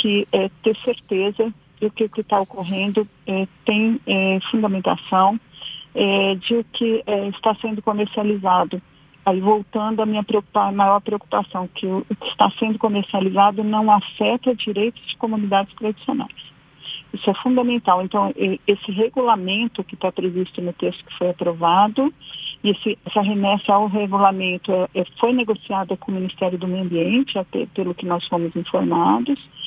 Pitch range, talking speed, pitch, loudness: 185-220 Hz, 155 wpm, 200 Hz, -20 LUFS